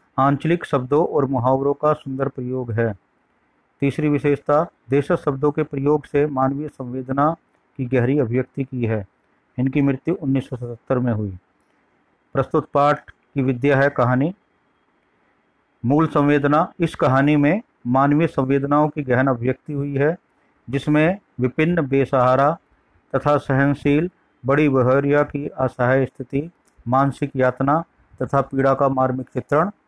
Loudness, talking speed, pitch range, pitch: -20 LUFS, 125 wpm, 130-150 Hz, 140 Hz